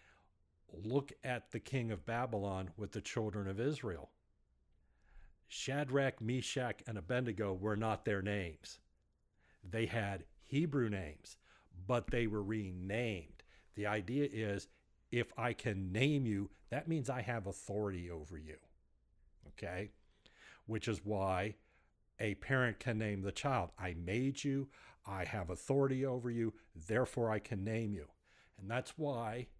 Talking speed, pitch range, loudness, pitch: 140 wpm, 95-125 Hz, -40 LUFS, 110 Hz